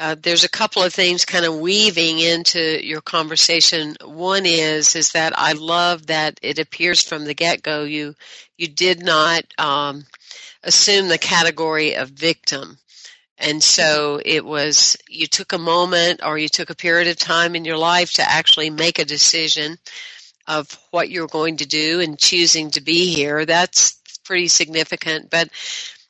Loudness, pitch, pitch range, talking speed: -16 LUFS, 165 Hz, 155-175 Hz, 170 wpm